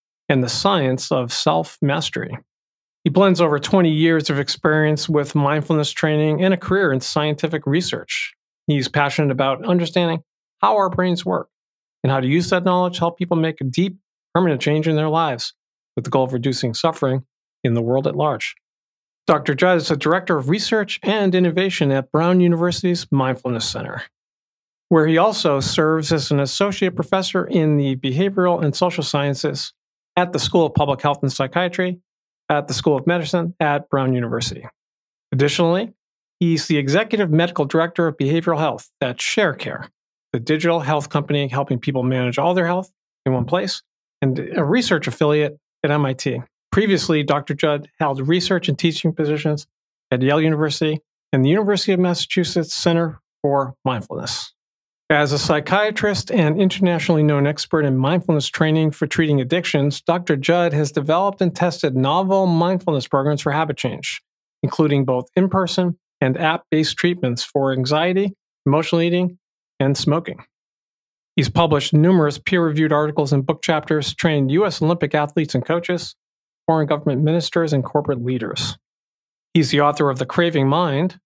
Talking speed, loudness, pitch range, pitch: 160 wpm, -19 LUFS, 145-175 Hz, 155 Hz